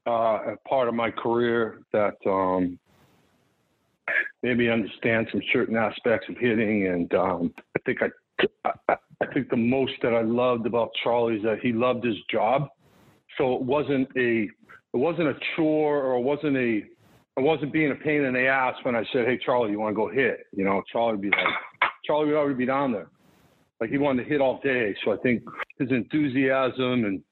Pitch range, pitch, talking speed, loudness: 115-135 Hz, 125 Hz, 200 wpm, -25 LUFS